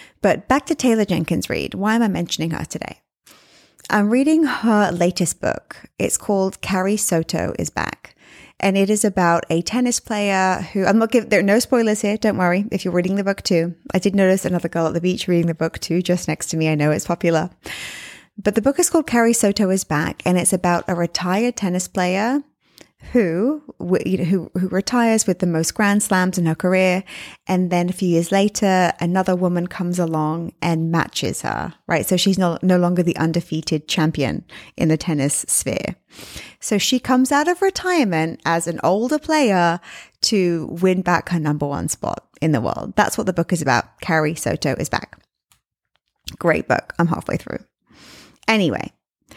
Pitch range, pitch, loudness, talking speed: 170-210 Hz, 185 Hz, -19 LUFS, 190 wpm